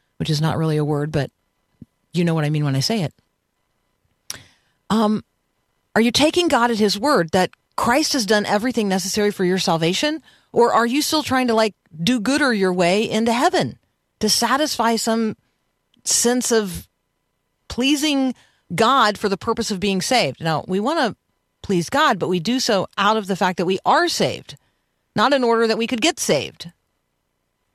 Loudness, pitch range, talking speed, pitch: -19 LUFS, 180-245 Hz, 185 wpm, 215 Hz